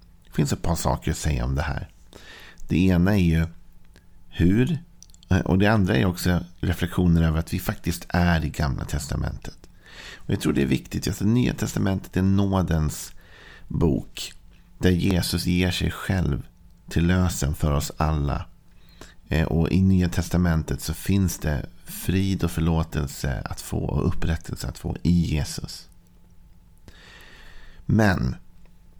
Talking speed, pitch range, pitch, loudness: 145 wpm, 80-90 Hz, 85 Hz, -24 LUFS